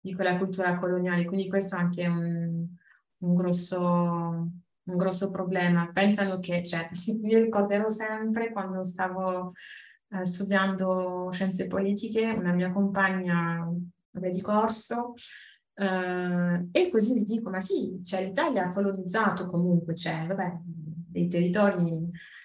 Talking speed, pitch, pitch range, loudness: 130 wpm, 185 Hz, 175-200 Hz, -28 LUFS